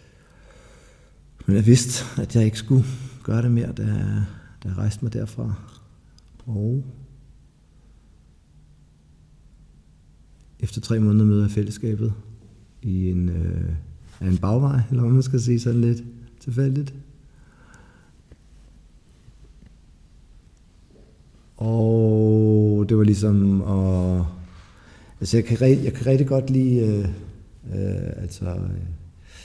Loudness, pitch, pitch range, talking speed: -22 LUFS, 105 Hz, 90-120 Hz, 110 wpm